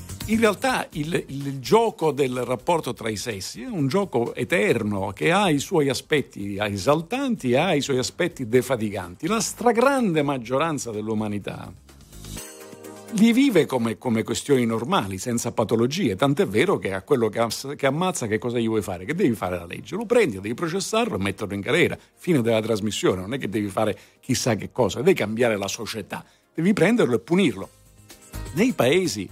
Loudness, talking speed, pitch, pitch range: -23 LUFS, 175 wpm, 120 Hz, 105-165 Hz